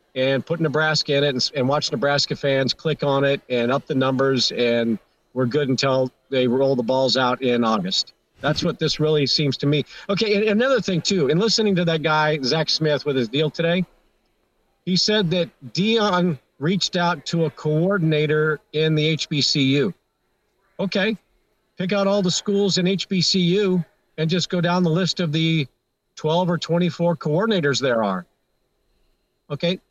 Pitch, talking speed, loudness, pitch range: 155 Hz, 175 wpm, -21 LUFS, 140-180 Hz